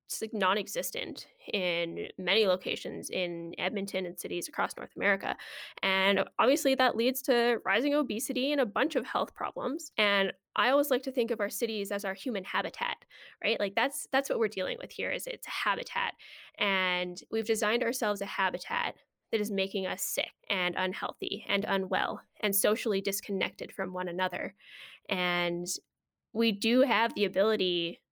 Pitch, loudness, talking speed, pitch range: 205 Hz, -30 LUFS, 170 wpm, 185-240 Hz